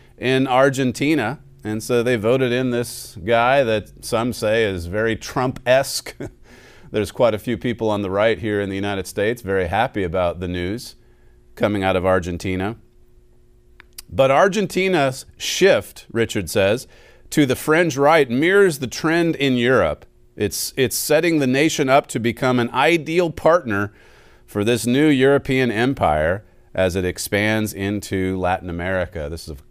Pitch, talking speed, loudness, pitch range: 115 Hz, 155 wpm, -19 LUFS, 95-135 Hz